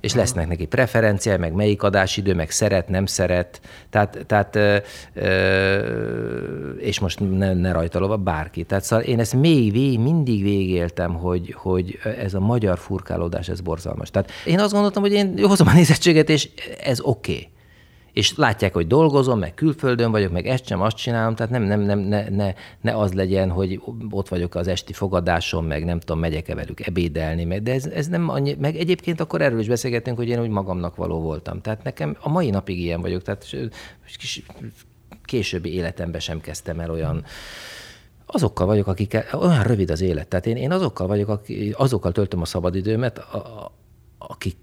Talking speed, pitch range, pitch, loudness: 180 wpm, 90-120 Hz, 100 Hz, -21 LUFS